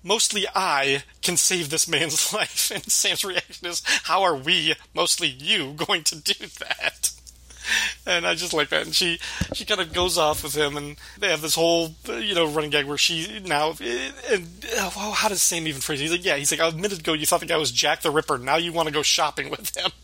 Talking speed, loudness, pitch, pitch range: 230 wpm, -22 LUFS, 165 Hz, 150-180 Hz